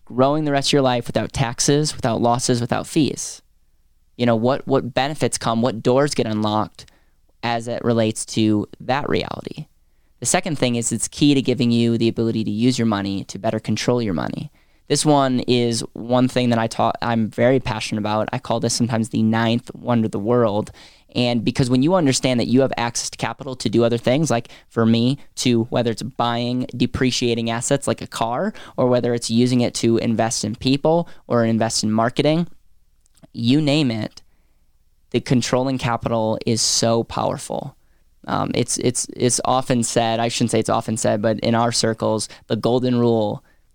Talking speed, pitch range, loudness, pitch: 190 wpm, 110-125 Hz, -20 LUFS, 120 Hz